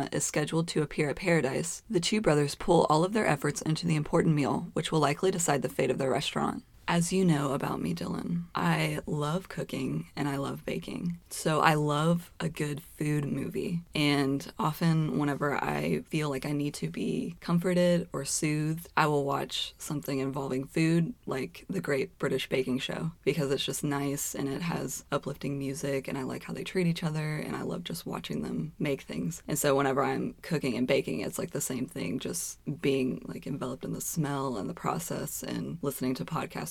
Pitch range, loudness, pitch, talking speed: 140-170 Hz, -30 LUFS, 150 Hz, 200 wpm